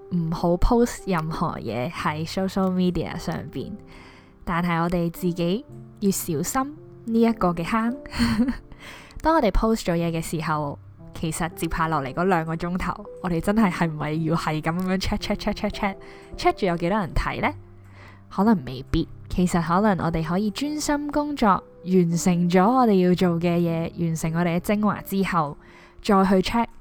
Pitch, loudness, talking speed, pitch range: 175 Hz, -24 LUFS, 330 characters per minute, 165-200 Hz